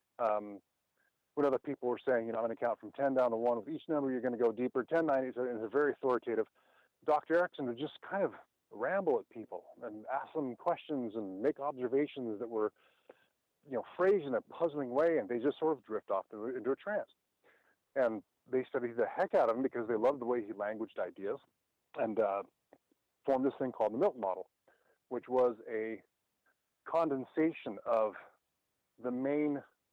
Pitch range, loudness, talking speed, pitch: 120-150 Hz, -35 LUFS, 200 wpm, 130 Hz